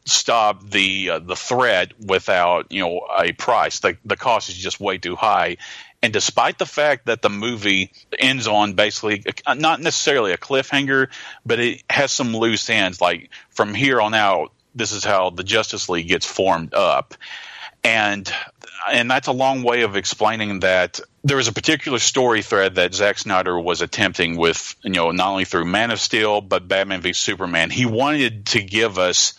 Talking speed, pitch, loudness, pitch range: 185 wpm, 110 Hz, -19 LUFS, 95-125 Hz